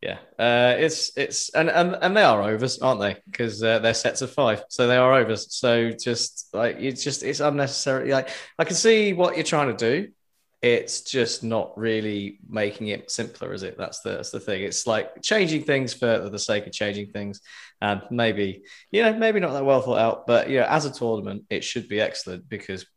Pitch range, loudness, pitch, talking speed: 110-150 Hz, -23 LUFS, 125 Hz, 215 wpm